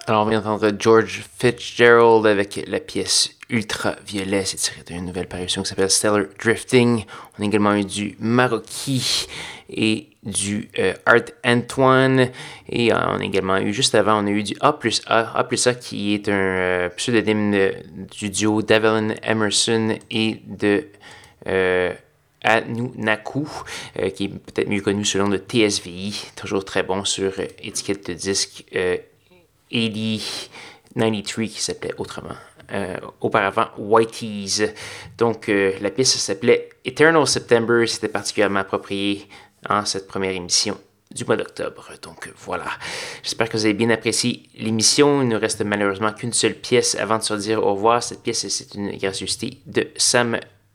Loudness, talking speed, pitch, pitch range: -20 LUFS, 160 wpm, 110 Hz, 100-120 Hz